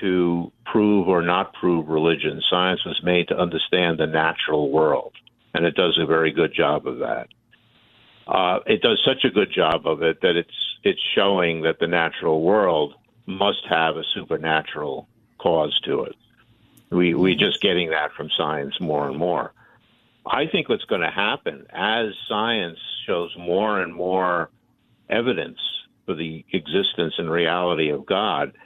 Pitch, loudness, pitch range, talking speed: 85 Hz, -22 LUFS, 80-90 Hz, 160 wpm